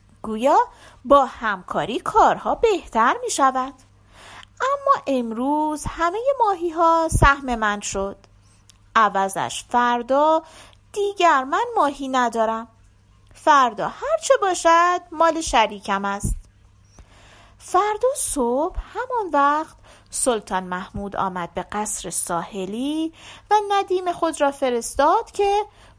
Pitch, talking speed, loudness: 275 Hz, 100 wpm, -21 LUFS